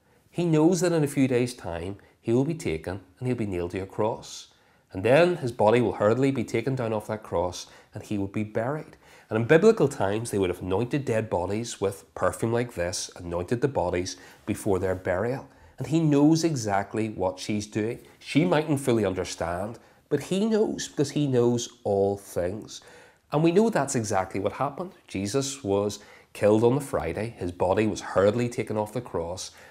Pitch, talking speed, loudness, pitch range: 110 Hz, 195 wpm, -26 LUFS, 95-135 Hz